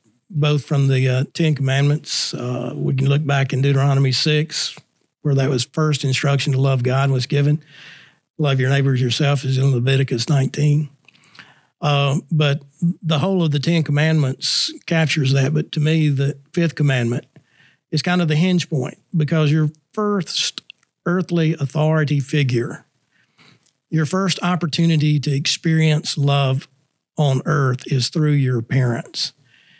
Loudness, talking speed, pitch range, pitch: -19 LUFS, 145 wpm, 135-155 Hz, 145 Hz